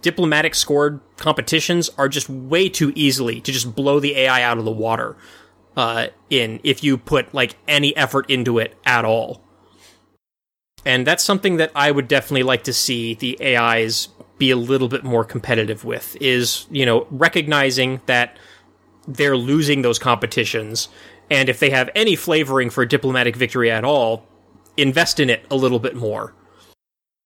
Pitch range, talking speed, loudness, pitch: 115-145 Hz, 165 wpm, -18 LUFS, 130 Hz